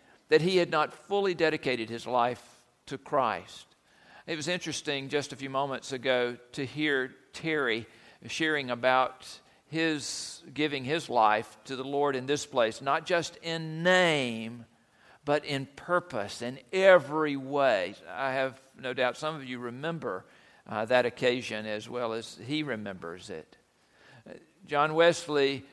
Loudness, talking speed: -29 LUFS, 145 wpm